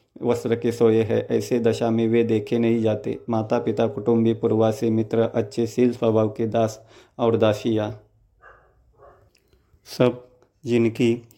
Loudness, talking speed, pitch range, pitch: -22 LUFS, 130 wpm, 110-120 Hz, 115 Hz